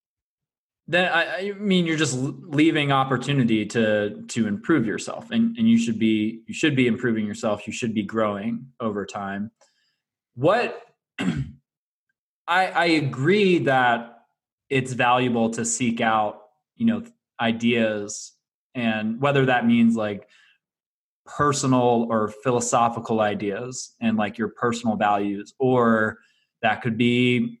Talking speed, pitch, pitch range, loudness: 125 wpm, 115 Hz, 110-135 Hz, -23 LUFS